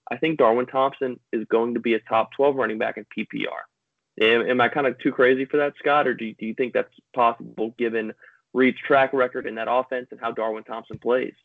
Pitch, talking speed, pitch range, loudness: 120 Hz, 235 wpm, 115-130 Hz, -23 LUFS